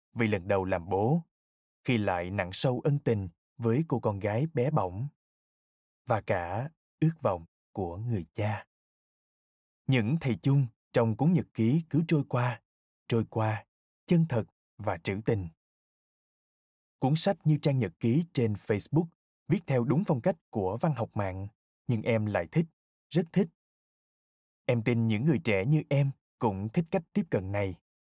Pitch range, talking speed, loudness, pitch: 100-155 Hz, 165 wpm, -30 LUFS, 115 Hz